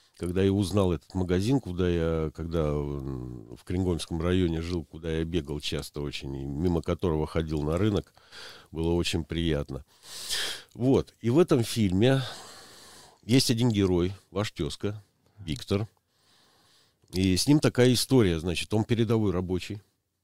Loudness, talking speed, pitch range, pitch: -27 LUFS, 135 wpm, 80-105 Hz, 90 Hz